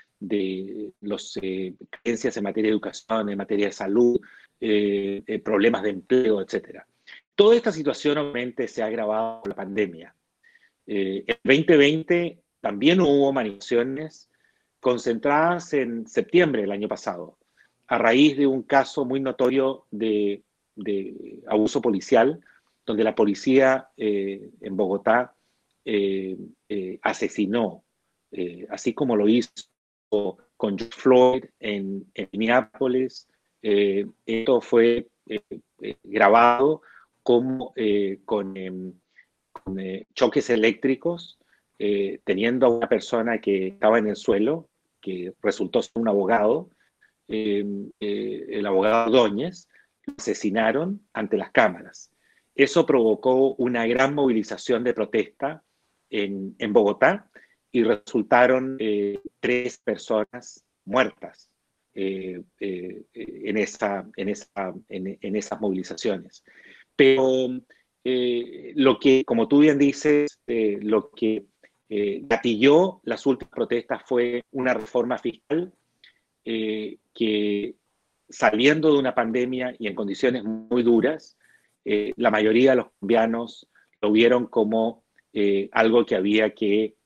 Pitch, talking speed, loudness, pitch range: 115 Hz, 125 wpm, -23 LUFS, 100-130 Hz